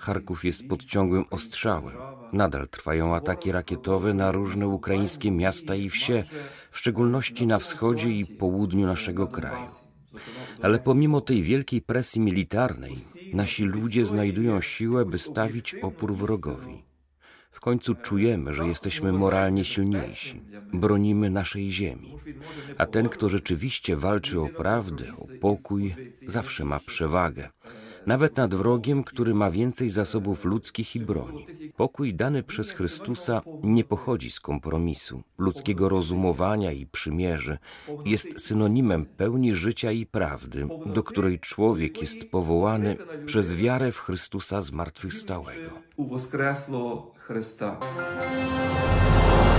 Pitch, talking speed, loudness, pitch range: 100 Hz, 115 wpm, -26 LUFS, 90-115 Hz